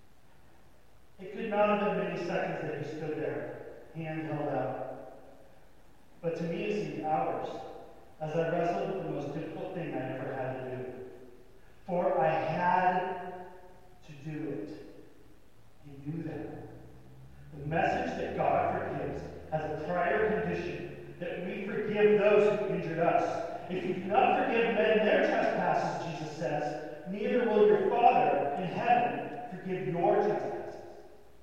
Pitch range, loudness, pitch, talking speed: 150-185 Hz, -31 LUFS, 165 Hz, 145 wpm